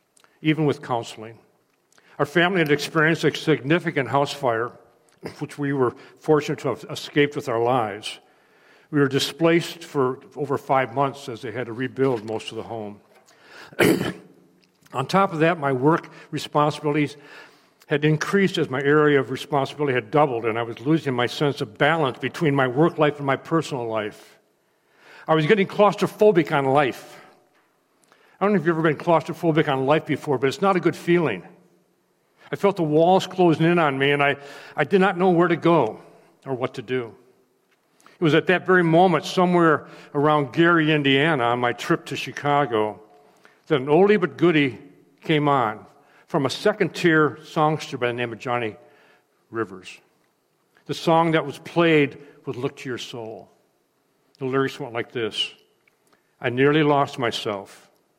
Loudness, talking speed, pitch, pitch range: -22 LUFS, 170 wpm, 145 Hz, 135-165 Hz